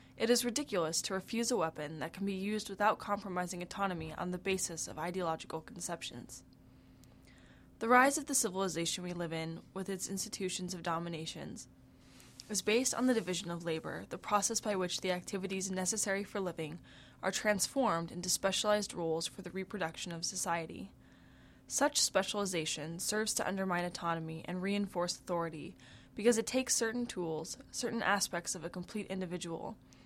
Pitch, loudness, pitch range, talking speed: 185 Hz, -35 LUFS, 170-210 Hz, 160 wpm